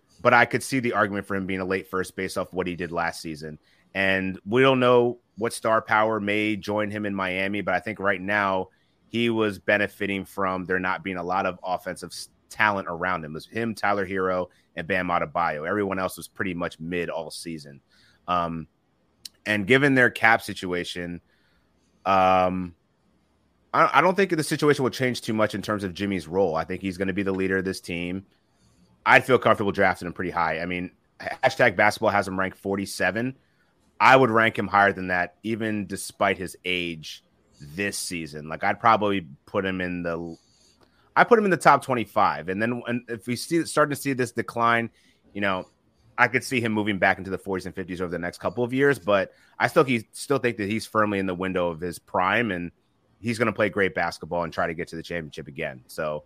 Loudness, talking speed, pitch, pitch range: -24 LUFS, 215 wpm, 100 Hz, 90-115 Hz